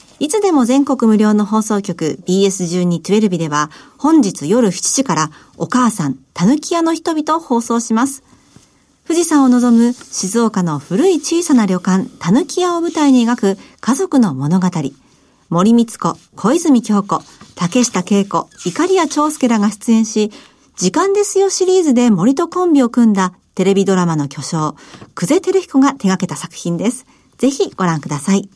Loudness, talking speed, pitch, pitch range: -15 LUFS, 290 characters per minute, 225 Hz, 185-280 Hz